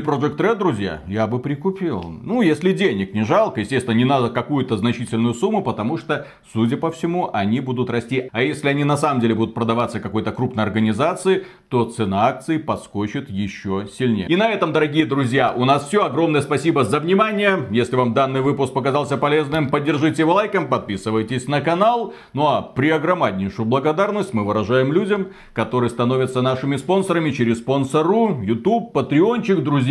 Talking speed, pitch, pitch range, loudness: 170 wpm, 135 Hz, 115-165 Hz, -19 LUFS